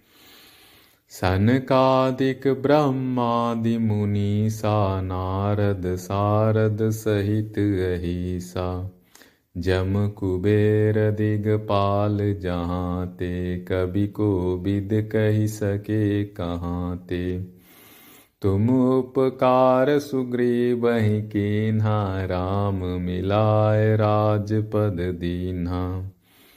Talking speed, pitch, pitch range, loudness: 65 wpm, 105 Hz, 90-110 Hz, -23 LUFS